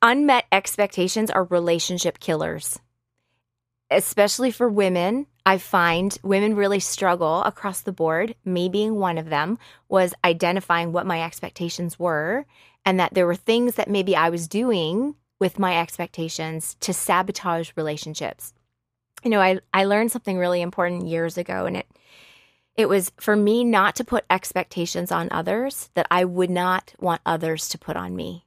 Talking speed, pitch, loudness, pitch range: 160 wpm, 180 Hz, -22 LUFS, 170-205 Hz